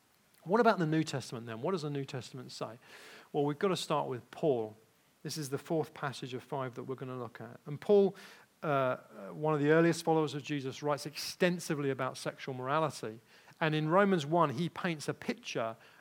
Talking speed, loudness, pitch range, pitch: 205 wpm, -33 LUFS, 130-165 Hz, 150 Hz